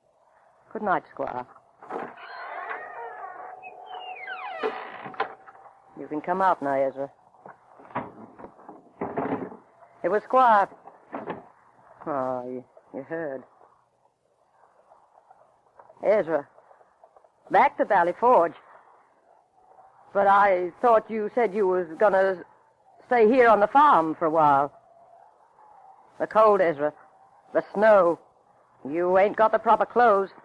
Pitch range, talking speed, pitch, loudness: 165-250 Hz, 95 wpm, 200 Hz, -23 LUFS